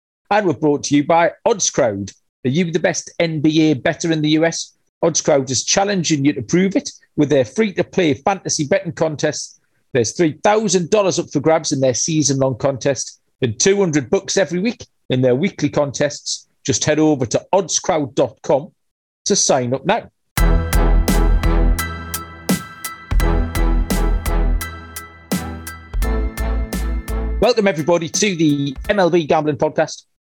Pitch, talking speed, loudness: 150 Hz, 130 wpm, -18 LUFS